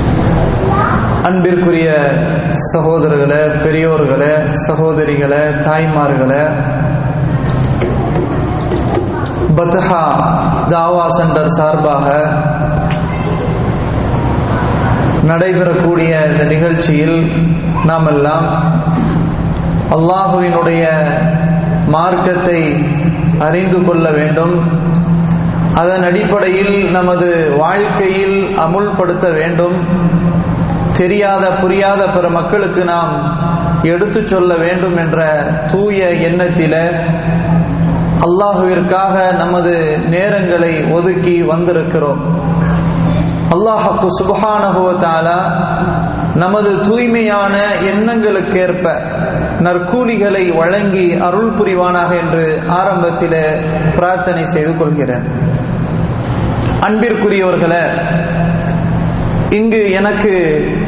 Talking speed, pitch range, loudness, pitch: 55 wpm, 155-180 Hz, -12 LUFS, 170 Hz